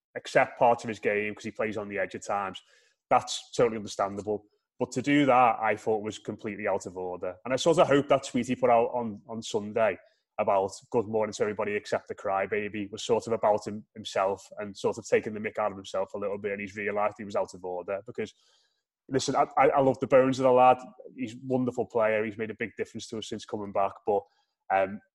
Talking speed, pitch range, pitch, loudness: 240 wpm, 100-125 Hz, 110 Hz, -28 LUFS